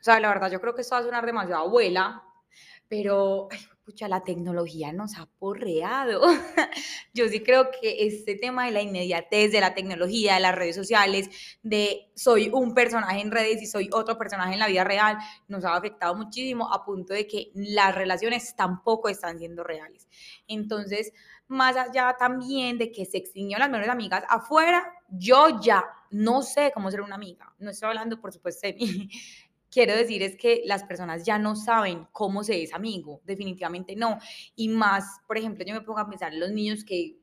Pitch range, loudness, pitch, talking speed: 190-230 Hz, -25 LUFS, 210 Hz, 195 wpm